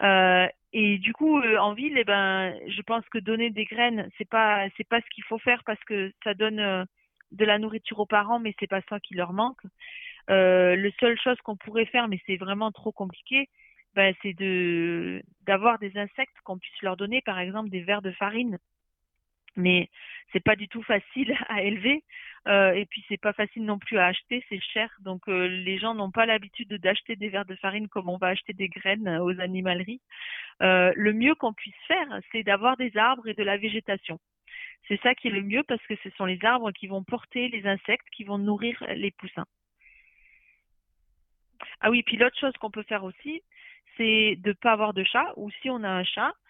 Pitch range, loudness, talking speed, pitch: 195-230 Hz, -26 LUFS, 215 wpm, 210 Hz